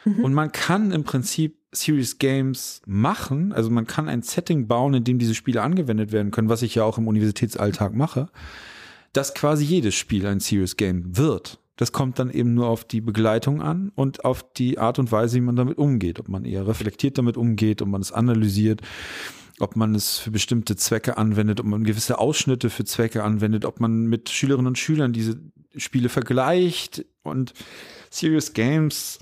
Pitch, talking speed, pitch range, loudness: 120 Hz, 185 wpm, 110-140 Hz, -22 LUFS